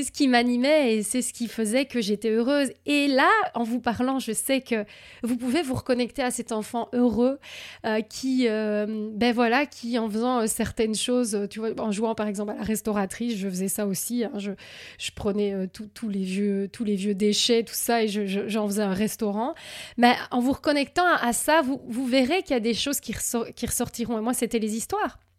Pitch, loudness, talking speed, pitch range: 235 Hz, -25 LUFS, 230 wpm, 215-255 Hz